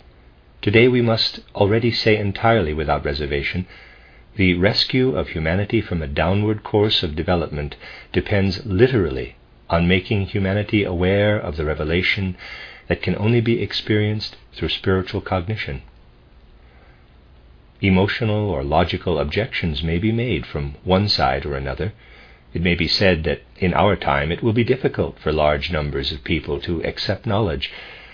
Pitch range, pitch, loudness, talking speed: 75-105 Hz, 90 Hz, -20 LUFS, 145 wpm